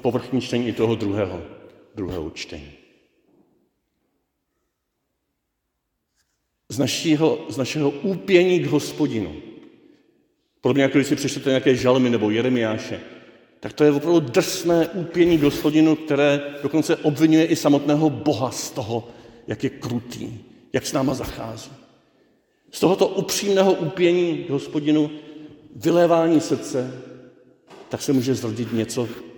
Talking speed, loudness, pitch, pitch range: 115 wpm, -21 LUFS, 145 Hz, 125-160 Hz